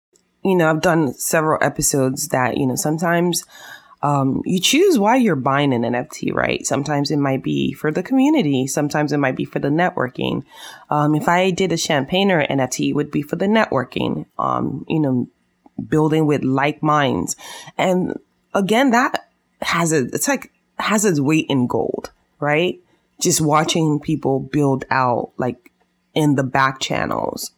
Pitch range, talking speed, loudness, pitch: 135-180 Hz, 170 wpm, -19 LUFS, 150 Hz